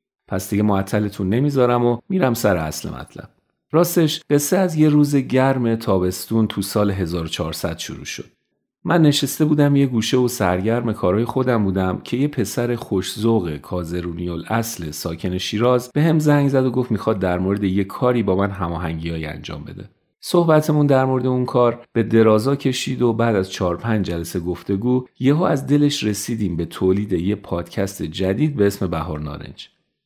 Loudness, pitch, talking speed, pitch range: -19 LUFS, 115 Hz, 165 wpm, 95-130 Hz